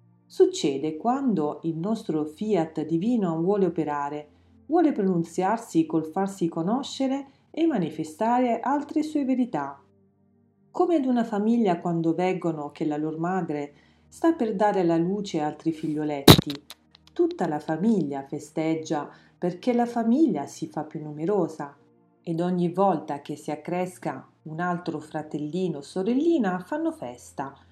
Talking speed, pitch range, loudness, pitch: 130 wpm, 150-225 Hz, -26 LUFS, 170 Hz